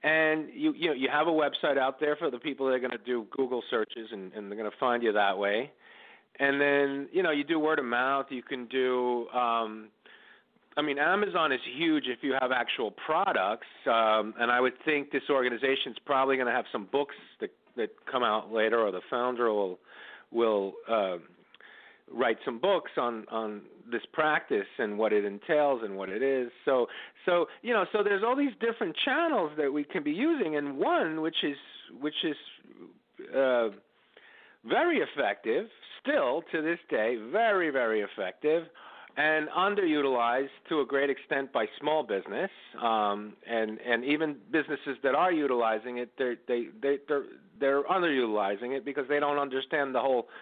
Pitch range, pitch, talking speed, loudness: 120-150 Hz, 135 Hz, 185 wpm, -29 LUFS